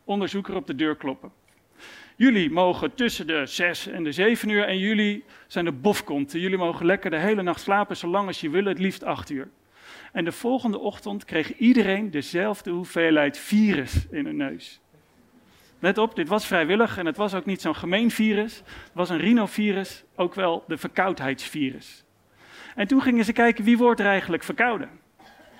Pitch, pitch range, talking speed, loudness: 195 Hz, 175-220 Hz, 185 wpm, -24 LUFS